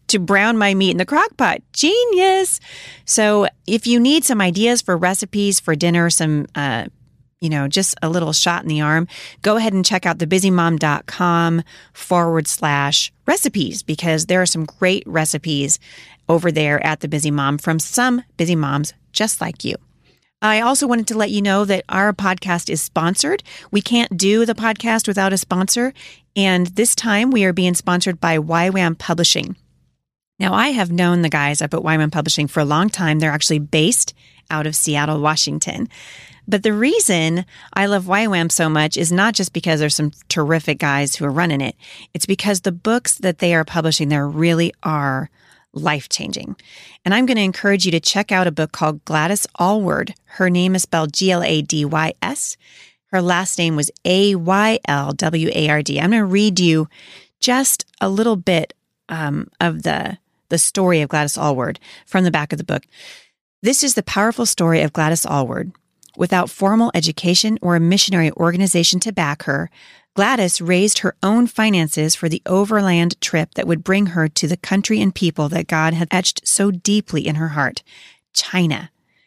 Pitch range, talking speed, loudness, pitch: 155-200 Hz, 185 wpm, -17 LUFS, 175 Hz